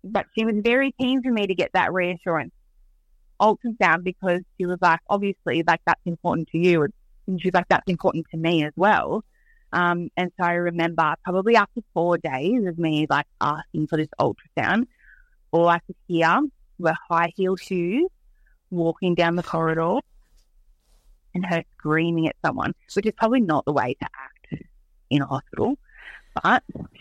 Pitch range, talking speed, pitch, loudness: 165-205 Hz, 170 wpm, 175 Hz, -23 LUFS